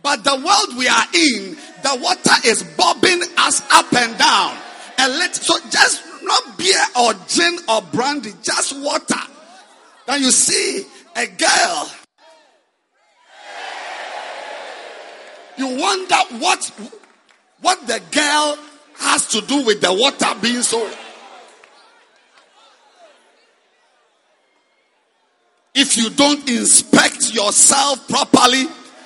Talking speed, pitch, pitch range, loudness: 105 wpm, 290 Hz, 260-355 Hz, -15 LUFS